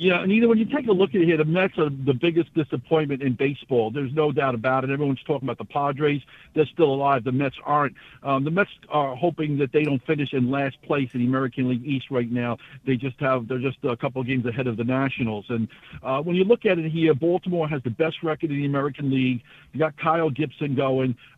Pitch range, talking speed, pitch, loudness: 130-160 Hz, 250 wpm, 140 Hz, -24 LUFS